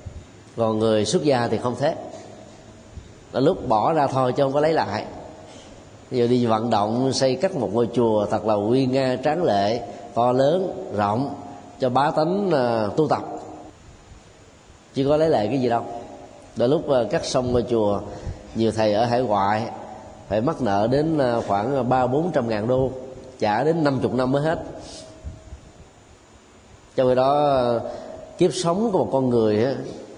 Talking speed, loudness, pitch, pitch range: 180 wpm, -22 LUFS, 120 Hz, 105-135 Hz